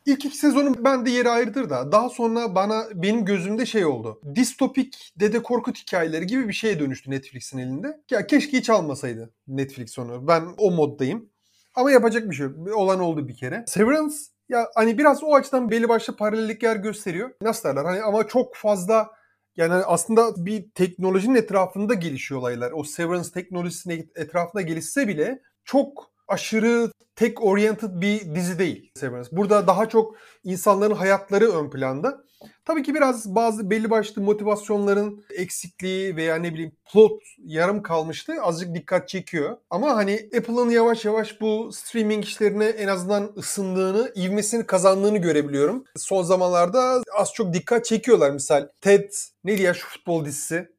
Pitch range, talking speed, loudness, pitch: 175-230 Hz, 155 wpm, -22 LUFS, 205 Hz